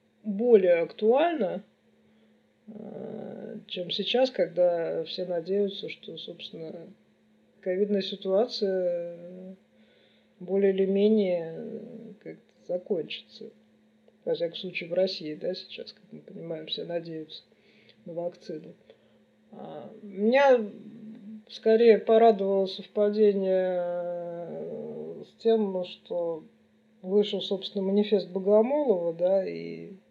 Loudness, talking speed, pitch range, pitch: -27 LUFS, 85 wpm, 180-220 Hz, 200 Hz